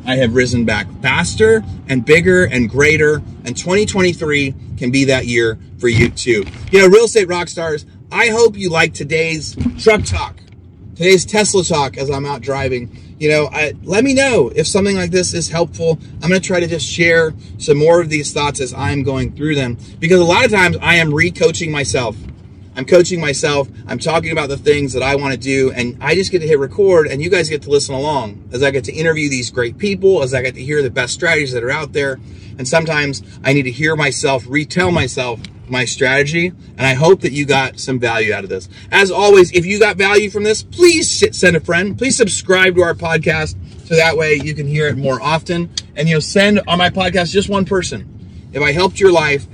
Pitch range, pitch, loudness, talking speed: 130-180 Hz, 150 Hz, -14 LUFS, 225 wpm